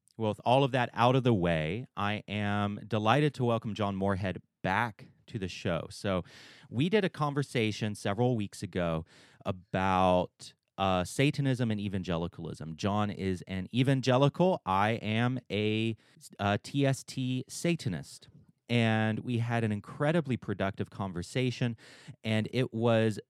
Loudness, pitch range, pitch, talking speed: -31 LUFS, 100-130 Hz, 110 Hz, 135 wpm